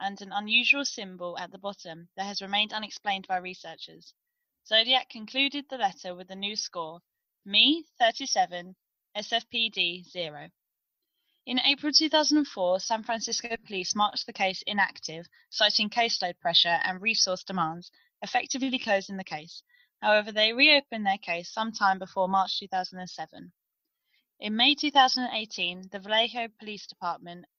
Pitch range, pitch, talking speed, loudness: 185-250 Hz, 210 Hz, 135 wpm, -26 LUFS